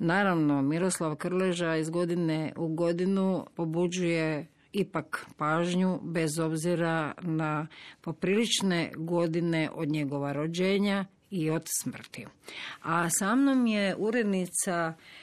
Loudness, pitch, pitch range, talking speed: -29 LUFS, 170 Hz, 160-185 Hz, 100 wpm